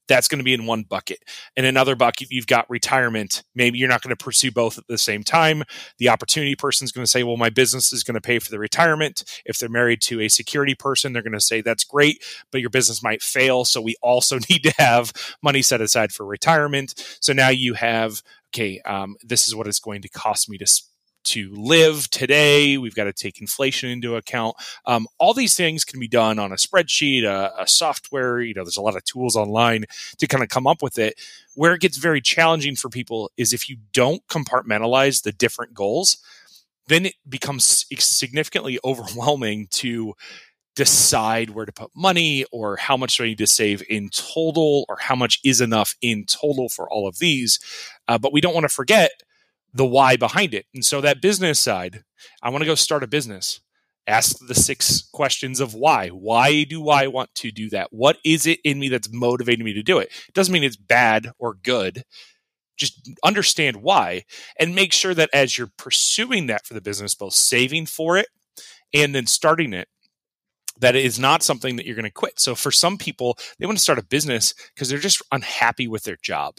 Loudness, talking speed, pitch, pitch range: -19 LUFS, 215 wpm, 125 Hz, 115-145 Hz